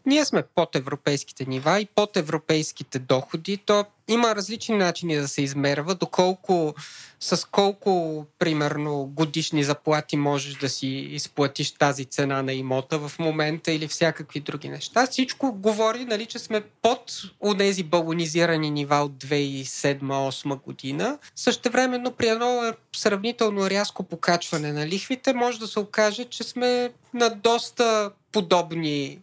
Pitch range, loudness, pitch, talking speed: 145-220 Hz, -25 LUFS, 170 Hz, 135 wpm